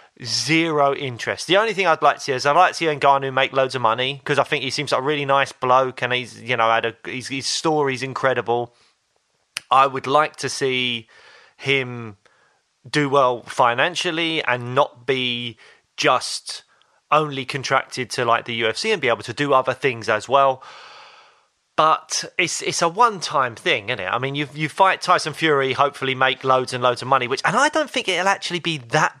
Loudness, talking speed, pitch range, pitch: -20 LUFS, 205 wpm, 125-155 Hz, 135 Hz